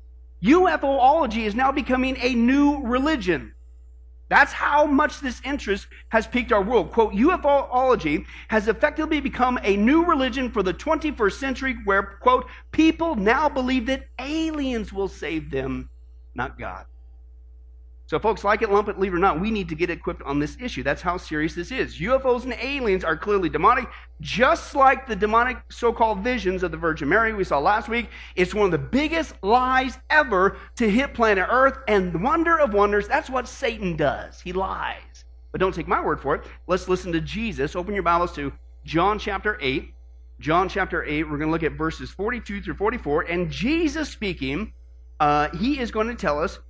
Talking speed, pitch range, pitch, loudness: 190 wpm, 160-260 Hz, 210 Hz, -22 LUFS